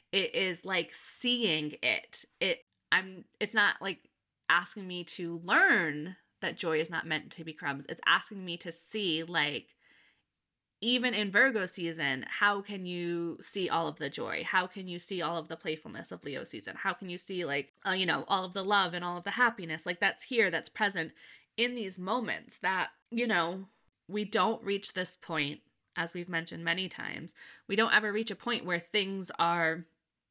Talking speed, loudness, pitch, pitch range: 195 wpm, -31 LUFS, 185 Hz, 165-210 Hz